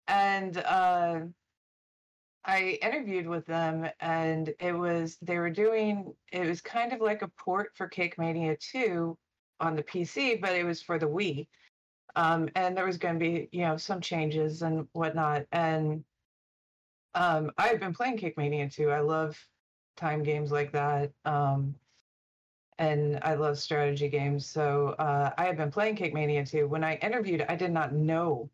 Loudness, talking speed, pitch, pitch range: -30 LUFS, 170 wpm, 165 Hz, 150-180 Hz